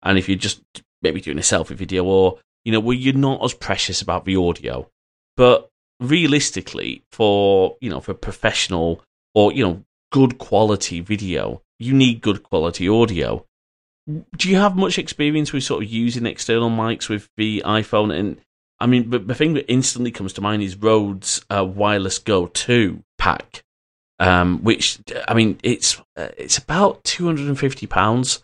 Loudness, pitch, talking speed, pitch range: -19 LUFS, 110 Hz, 170 wpm, 95-125 Hz